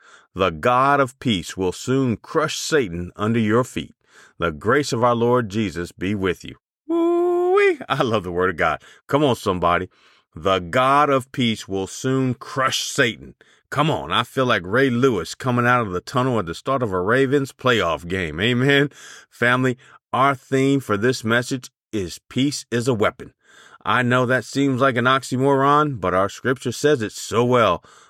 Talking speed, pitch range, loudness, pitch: 180 wpm, 105-135 Hz, -20 LUFS, 125 Hz